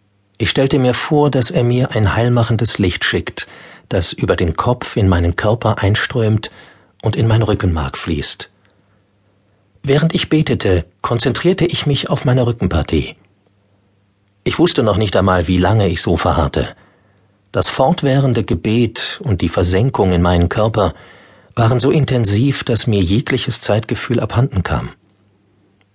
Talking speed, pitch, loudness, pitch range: 140 wpm, 105 Hz, -15 LUFS, 100-125 Hz